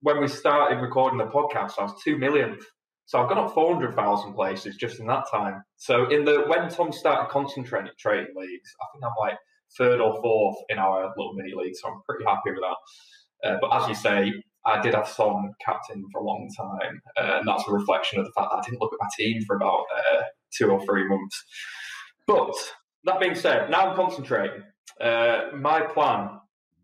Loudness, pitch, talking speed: -25 LUFS, 145 Hz, 210 wpm